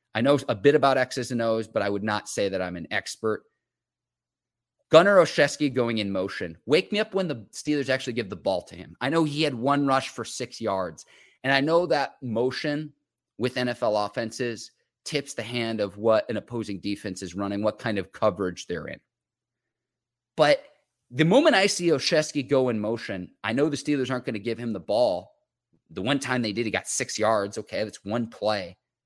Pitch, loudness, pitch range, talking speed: 120 Hz, -25 LUFS, 105-140 Hz, 205 wpm